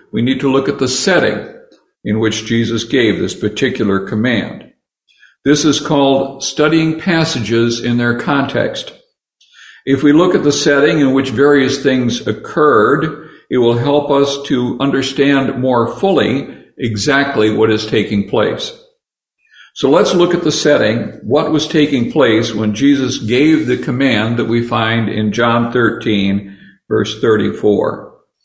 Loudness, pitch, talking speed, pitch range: -13 LUFS, 135 Hz, 145 wpm, 115-145 Hz